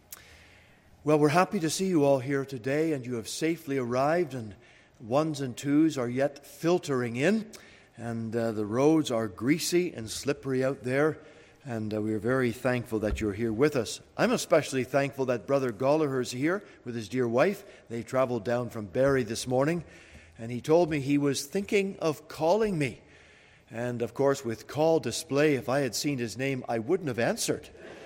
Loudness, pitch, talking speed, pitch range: -28 LUFS, 135 Hz, 185 wpm, 120-155 Hz